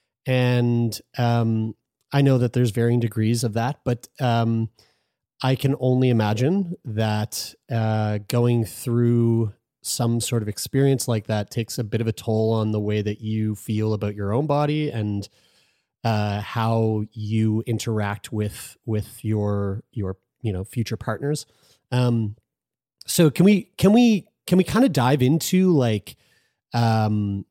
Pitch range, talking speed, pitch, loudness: 110-130 Hz, 150 wpm, 115 Hz, -23 LUFS